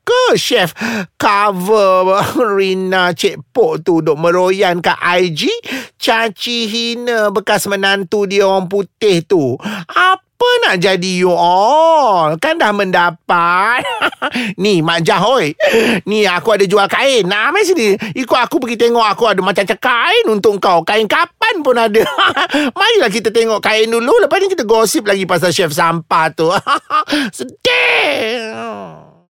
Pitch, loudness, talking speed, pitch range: 220 Hz, -12 LUFS, 135 wpm, 190-280 Hz